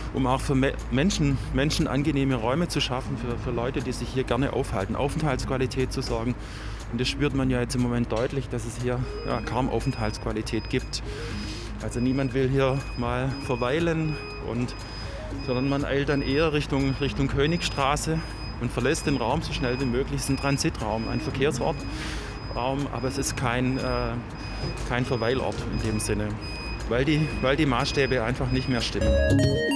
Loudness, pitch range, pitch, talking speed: -27 LUFS, 115-135 Hz, 125 Hz, 170 wpm